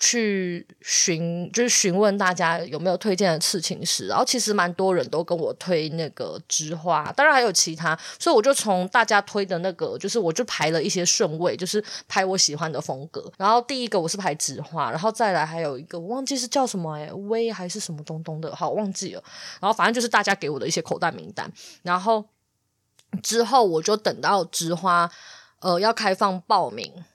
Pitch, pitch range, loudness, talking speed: 185 Hz, 165-215 Hz, -23 LUFS, 310 characters per minute